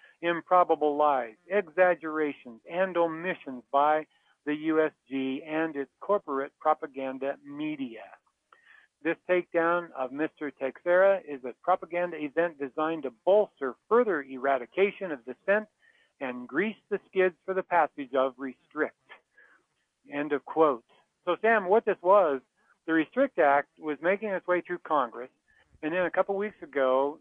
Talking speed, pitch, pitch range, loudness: 135 wpm, 160 Hz, 140-190 Hz, -28 LUFS